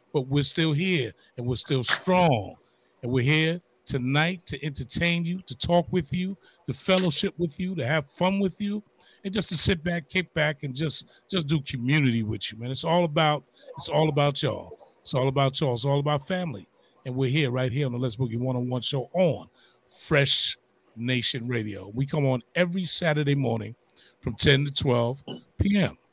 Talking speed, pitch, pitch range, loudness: 200 wpm, 145 Hz, 130-170 Hz, -26 LUFS